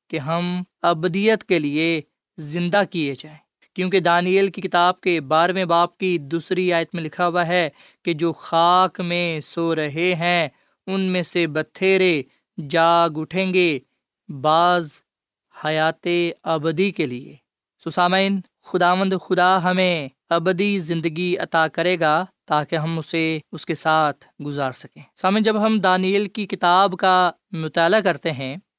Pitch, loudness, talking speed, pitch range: 175 Hz, -20 LUFS, 145 wpm, 160-185 Hz